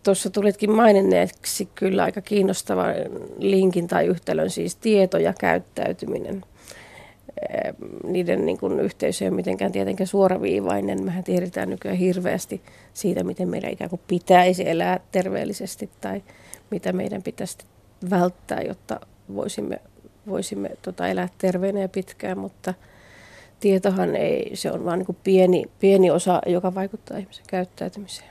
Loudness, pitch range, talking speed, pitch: -23 LUFS, 175-195 Hz, 125 wpm, 185 Hz